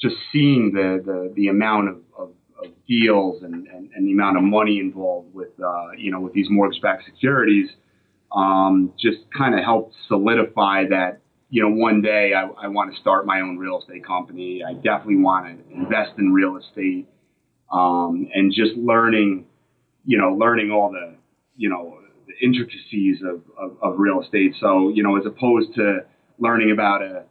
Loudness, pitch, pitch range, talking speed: -20 LUFS, 100 Hz, 95-115 Hz, 180 wpm